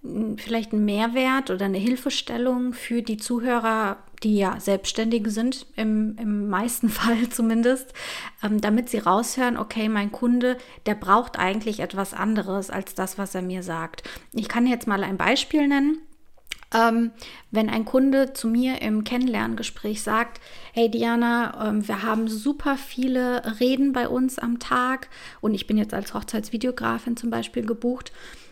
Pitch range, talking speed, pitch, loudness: 210-250 Hz, 145 wpm, 230 Hz, -24 LUFS